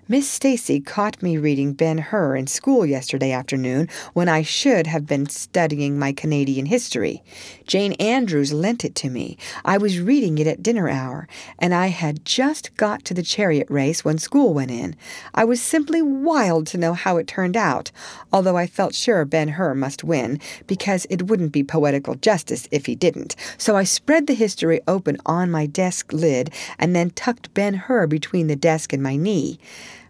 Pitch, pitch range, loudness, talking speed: 165 Hz, 150-205 Hz, -20 LUFS, 185 wpm